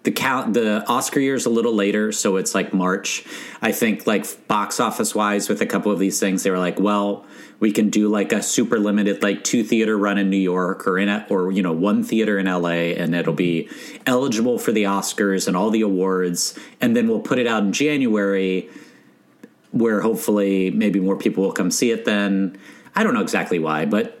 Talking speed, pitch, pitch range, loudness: 220 wpm, 100 Hz, 95-105 Hz, -20 LUFS